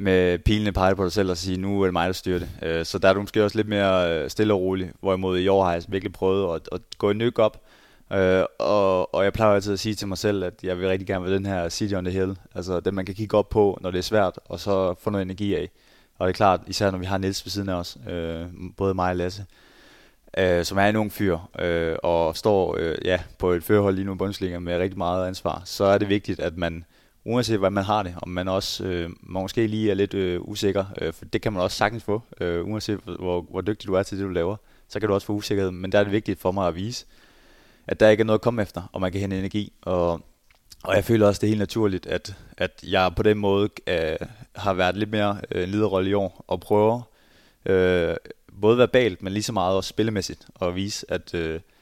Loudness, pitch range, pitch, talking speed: -24 LUFS, 90-105 Hz, 95 Hz, 250 wpm